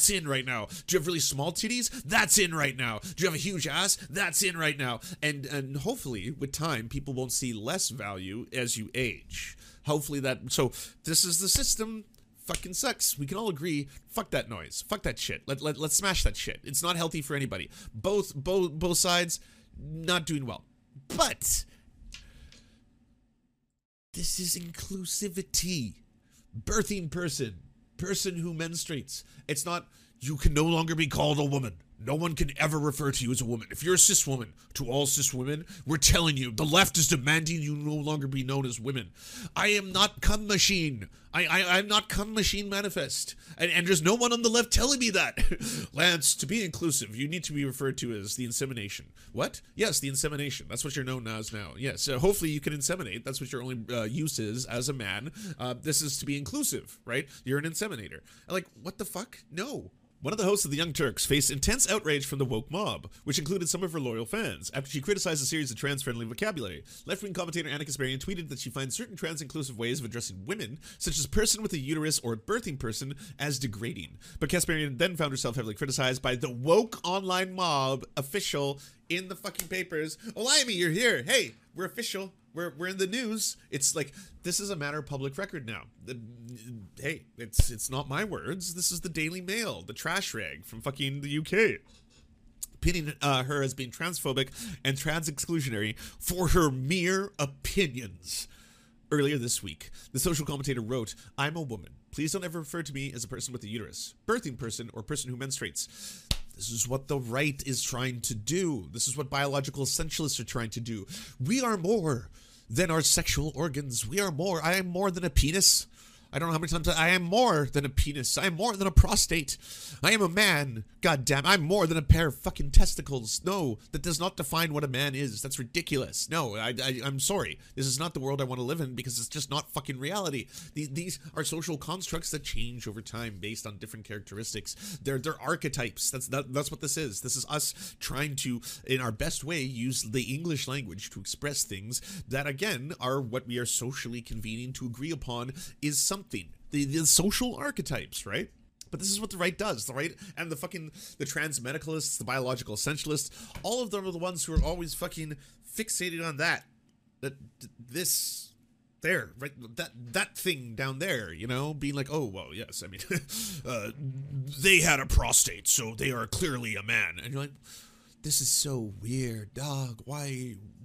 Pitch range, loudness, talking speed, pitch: 125-175 Hz, -29 LUFS, 205 wpm, 145 Hz